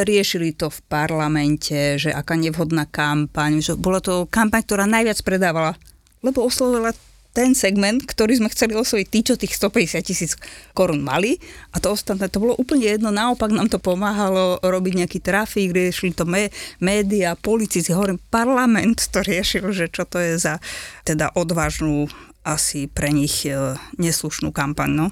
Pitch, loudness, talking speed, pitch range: 185 Hz, -20 LUFS, 155 wpm, 160-215 Hz